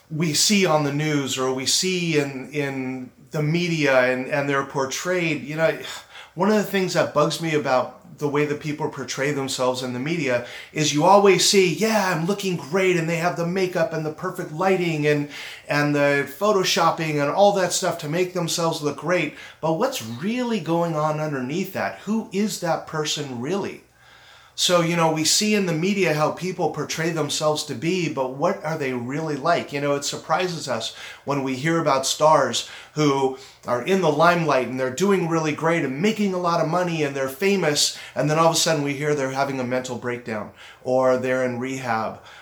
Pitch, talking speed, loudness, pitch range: 155 Hz, 200 wpm, -22 LUFS, 140-175 Hz